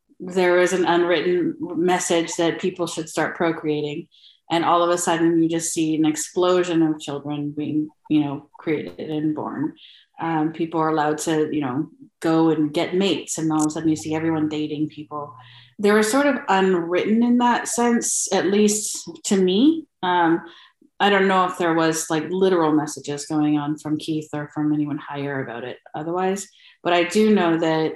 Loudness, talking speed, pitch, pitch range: -21 LUFS, 185 wpm, 165 Hz, 150-185 Hz